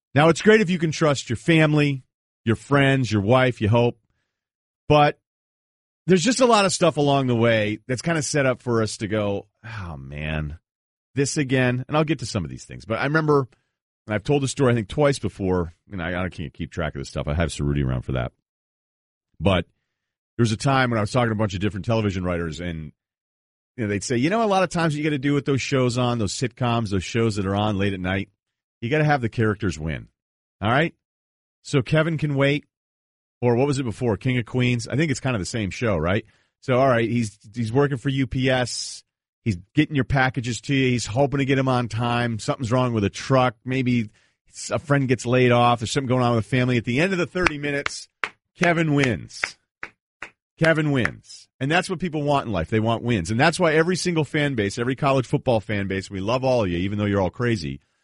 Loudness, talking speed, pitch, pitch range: -22 LUFS, 240 wpm, 120 Hz, 105-140 Hz